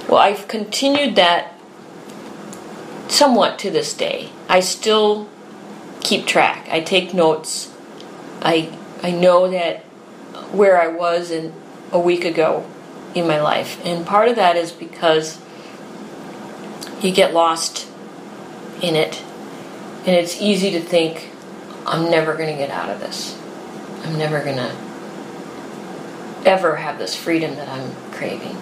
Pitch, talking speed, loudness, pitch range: 170 Hz, 135 wpm, -18 LUFS, 160-185 Hz